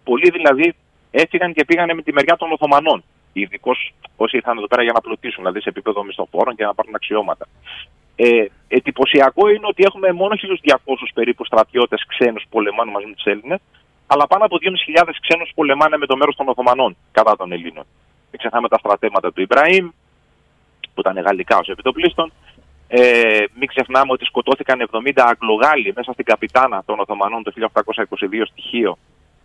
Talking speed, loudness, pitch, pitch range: 170 wpm, -16 LUFS, 130 Hz, 115-165 Hz